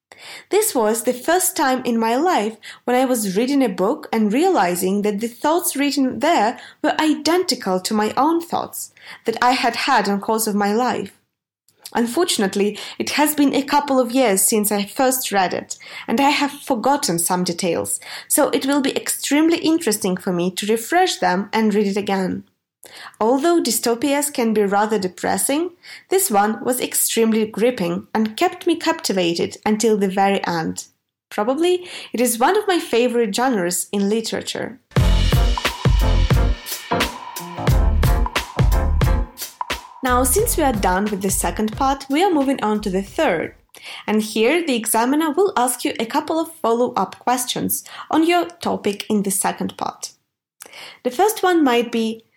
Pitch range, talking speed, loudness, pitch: 205-285 Hz, 160 wpm, -19 LUFS, 235 Hz